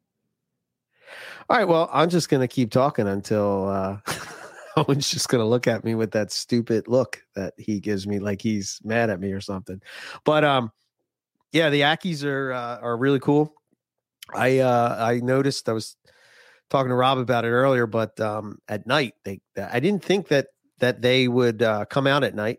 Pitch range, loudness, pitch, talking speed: 105-140 Hz, -23 LUFS, 120 Hz, 185 wpm